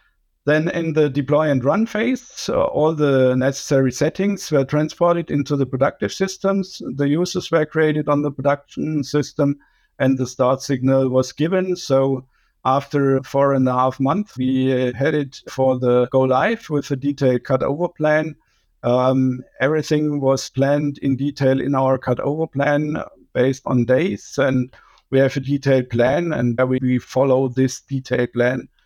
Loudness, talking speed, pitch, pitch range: -19 LUFS, 160 wpm, 140 Hz, 130-150 Hz